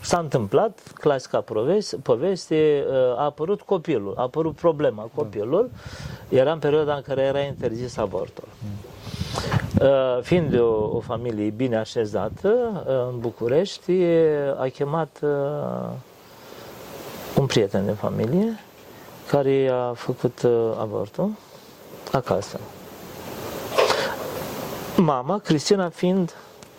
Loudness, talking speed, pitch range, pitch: -23 LUFS, 90 wpm, 125-175 Hz, 140 Hz